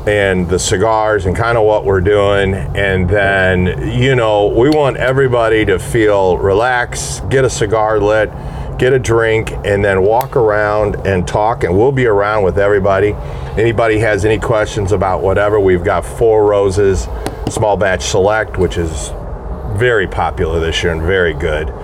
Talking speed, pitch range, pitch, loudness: 165 wpm, 95-110 Hz, 105 Hz, -13 LUFS